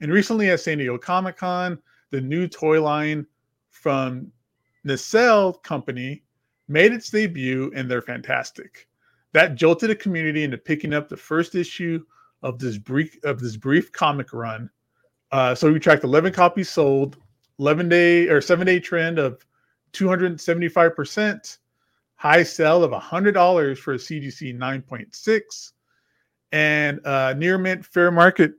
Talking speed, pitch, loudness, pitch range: 140 wpm, 155 Hz, -20 LUFS, 135-180 Hz